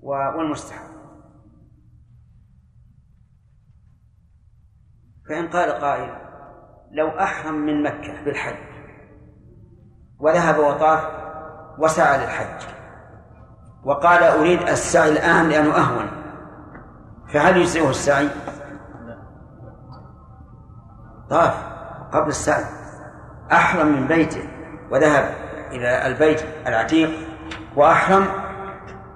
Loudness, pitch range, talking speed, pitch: -19 LUFS, 115-160 Hz, 70 wpm, 150 Hz